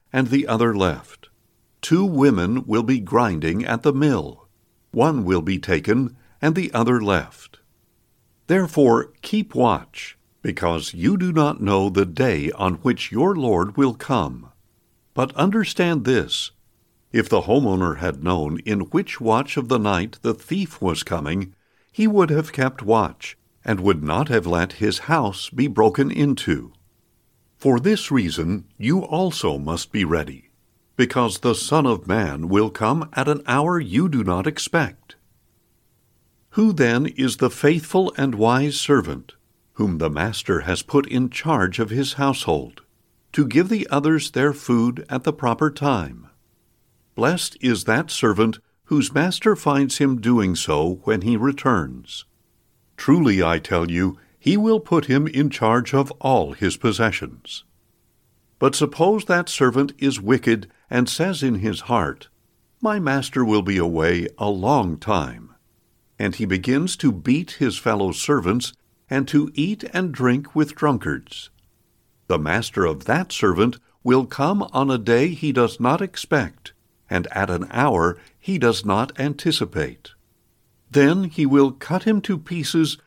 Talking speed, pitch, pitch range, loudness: 150 wpm, 125 Hz, 110-145 Hz, -21 LUFS